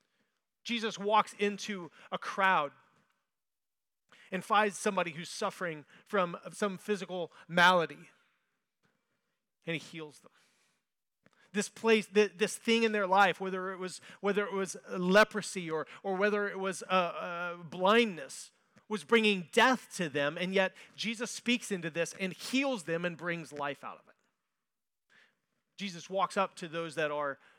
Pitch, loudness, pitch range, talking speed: 190 Hz, -32 LUFS, 175-210 Hz, 145 wpm